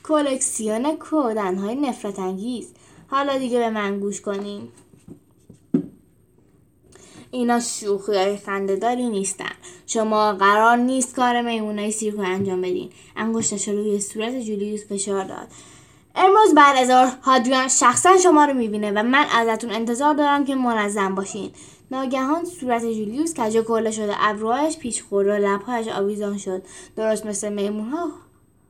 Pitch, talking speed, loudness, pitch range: 225 Hz, 130 wpm, -20 LUFS, 205-260 Hz